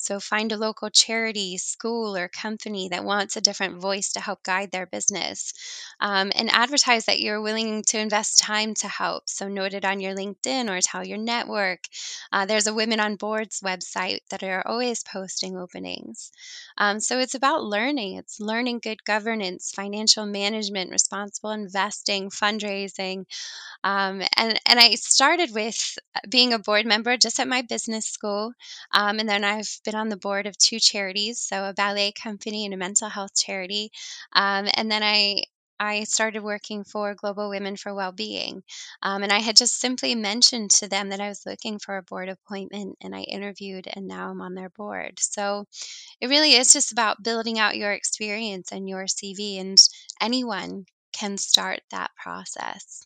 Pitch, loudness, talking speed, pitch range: 205 Hz, -22 LUFS, 180 wpm, 195-220 Hz